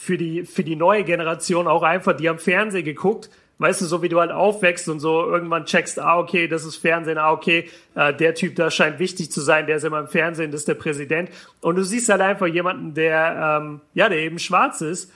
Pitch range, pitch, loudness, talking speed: 160-180 Hz, 170 Hz, -20 LUFS, 240 wpm